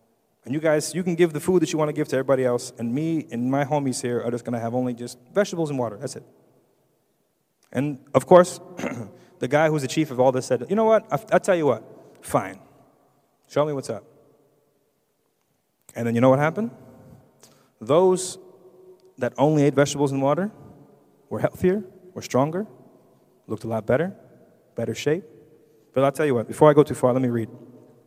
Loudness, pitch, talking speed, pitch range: -23 LUFS, 145 Hz, 200 wpm, 125-165 Hz